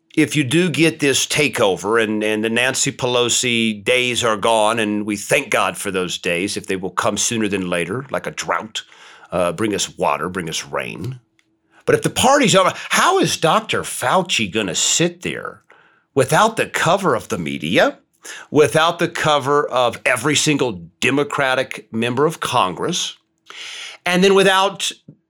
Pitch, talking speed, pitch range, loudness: 125 Hz, 165 wpm, 110-155 Hz, -17 LUFS